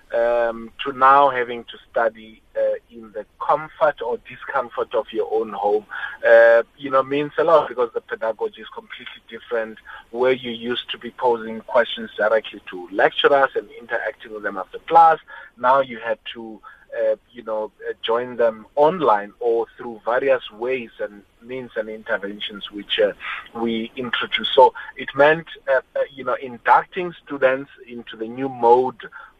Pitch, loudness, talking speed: 130 Hz, -20 LUFS, 165 wpm